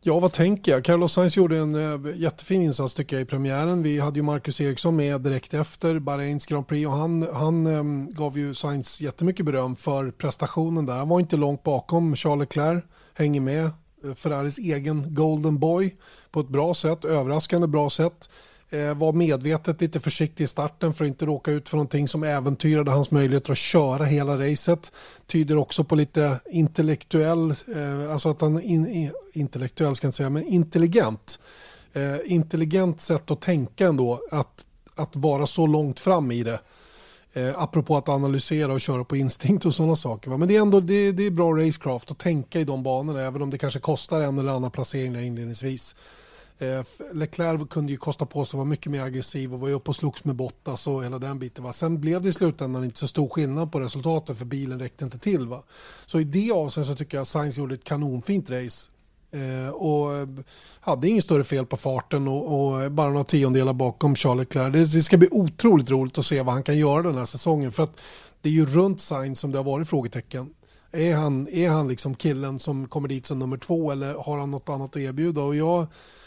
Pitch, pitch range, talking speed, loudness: 150 Hz, 135-160 Hz, 205 wpm, -24 LUFS